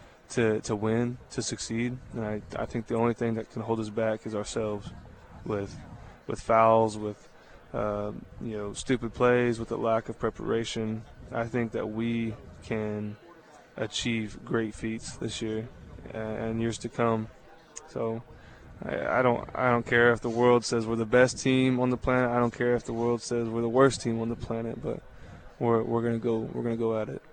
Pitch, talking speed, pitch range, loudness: 115 Hz, 195 wpm, 110-120 Hz, -29 LUFS